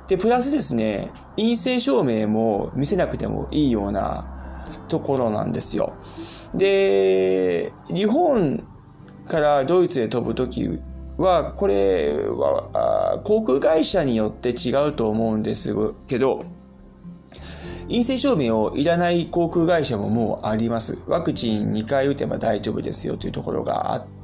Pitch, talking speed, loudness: 120 Hz, 270 characters per minute, -22 LUFS